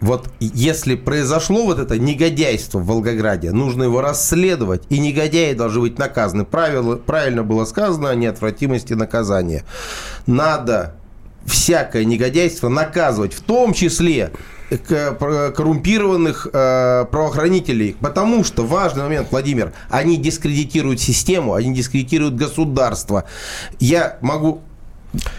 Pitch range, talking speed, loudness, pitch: 120-160 Hz, 110 wpm, -17 LUFS, 140 Hz